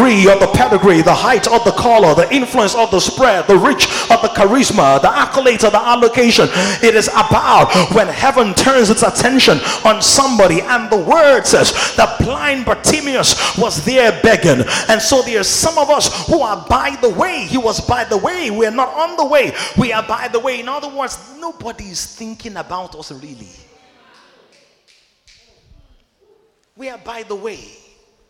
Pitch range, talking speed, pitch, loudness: 215-270 Hz, 180 wpm, 240 Hz, -12 LUFS